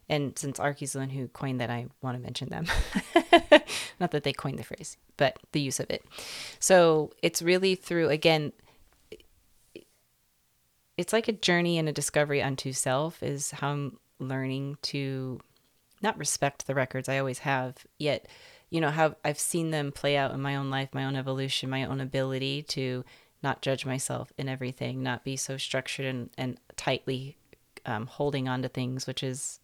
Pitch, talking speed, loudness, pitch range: 135 Hz, 180 wpm, -29 LUFS, 130-150 Hz